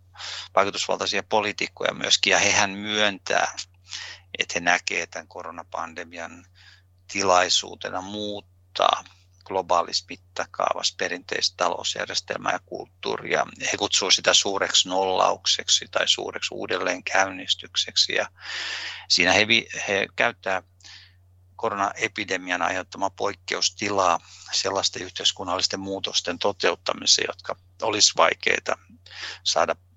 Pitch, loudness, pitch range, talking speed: 90 Hz, -23 LUFS, 90-95 Hz, 90 wpm